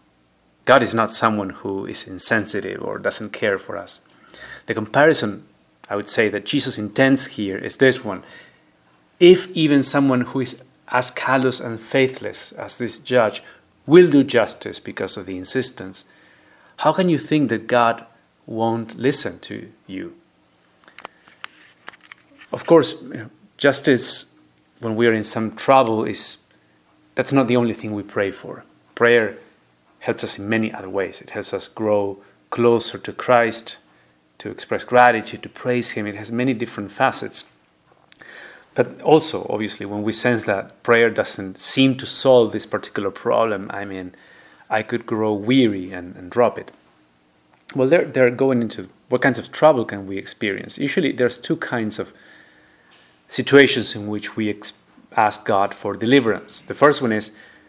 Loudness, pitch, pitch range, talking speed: -19 LUFS, 115 Hz, 105-130 Hz, 155 wpm